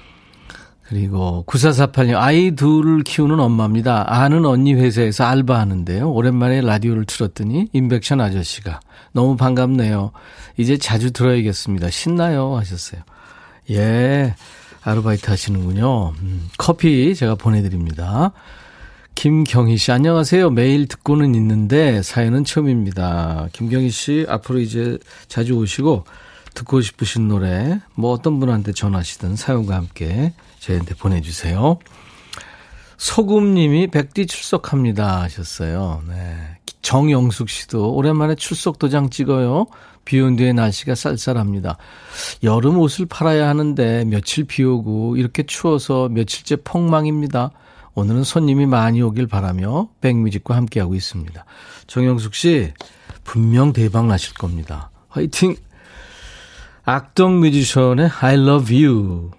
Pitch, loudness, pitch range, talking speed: 125 Hz, -17 LUFS, 105-145 Hz, 295 characters per minute